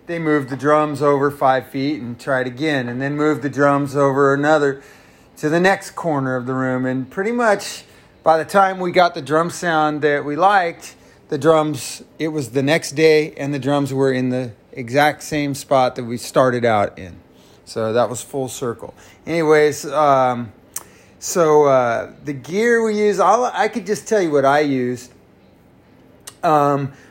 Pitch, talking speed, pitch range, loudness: 145 Hz, 180 wpm, 130-160 Hz, -18 LUFS